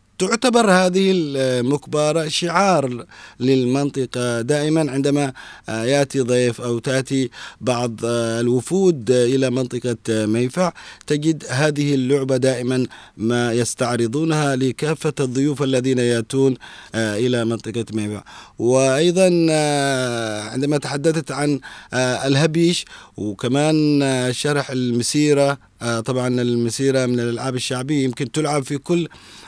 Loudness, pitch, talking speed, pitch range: -19 LUFS, 130 Hz, 95 wpm, 120-150 Hz